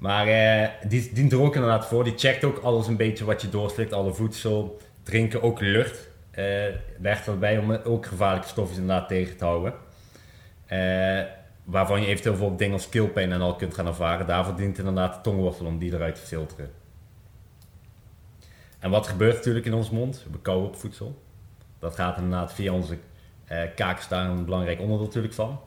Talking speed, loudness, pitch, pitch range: 185 wpm, -26 LUFS, 100 Hz, 90-110 Hz